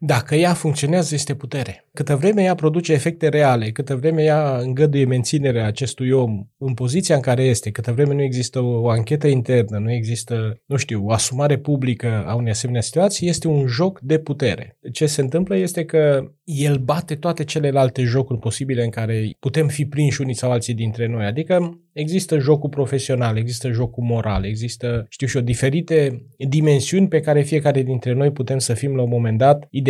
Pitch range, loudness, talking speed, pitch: 120-150 Hz, -19 LUFS, 185 wpm, 135 Hz